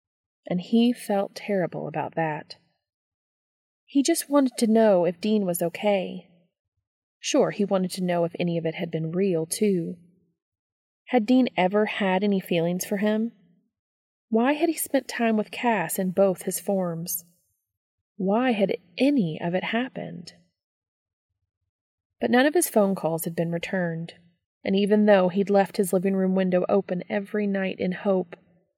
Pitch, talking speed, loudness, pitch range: 185 Hz, 160 wpm, -24 LUFS, 170-210 Hz